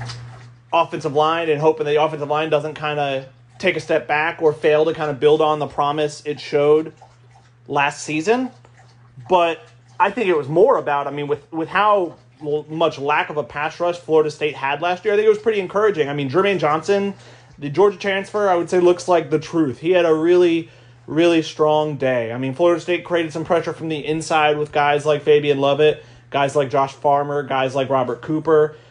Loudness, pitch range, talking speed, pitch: -19 LUFS, 140-165 Hz, 210 wpm, 150 Hz